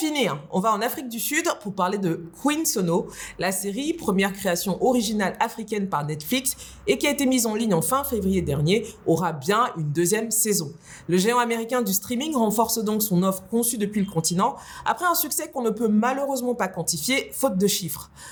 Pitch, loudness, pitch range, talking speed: 215 Hz, -23 LUFS, 180-245 Hz, 205 wpm